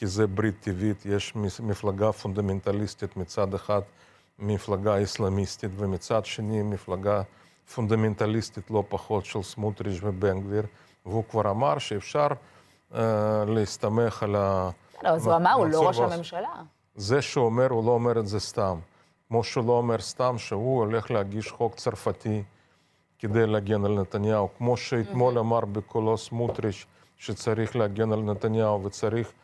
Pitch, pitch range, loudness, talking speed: 105 Hz, 100-115 Hz, -27 LUFS, 140 wpm